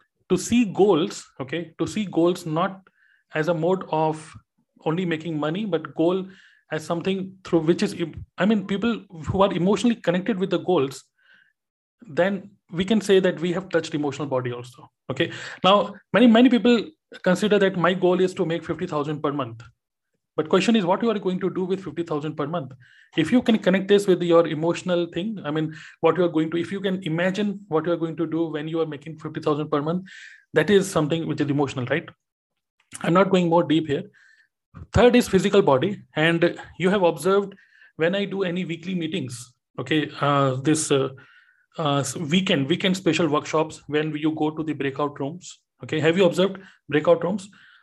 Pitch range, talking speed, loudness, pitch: 155-190 Hz, 190 wpm, -23 LUFS, 170 Hz